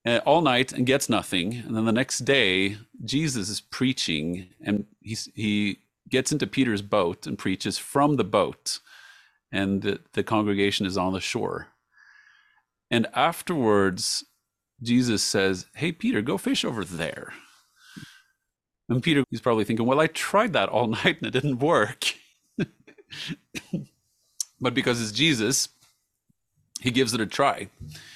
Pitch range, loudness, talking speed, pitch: 100-135 Hz, -25 LUFS, 145 wpm, 115 Hz